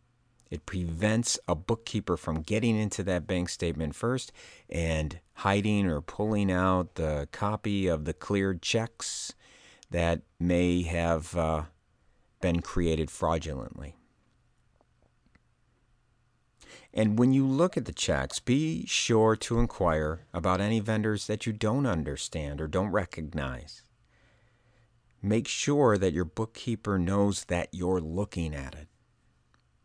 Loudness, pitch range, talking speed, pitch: -29 LUFS, 85-115 Hz, 125 wpm, 100 Hz